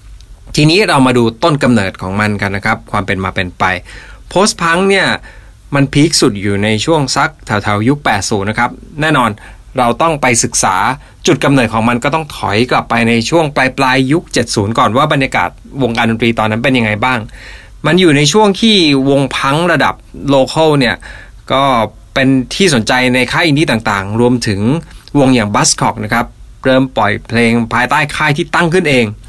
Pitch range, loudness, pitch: 110-145 Hz, -12 LUFS, 125 Hz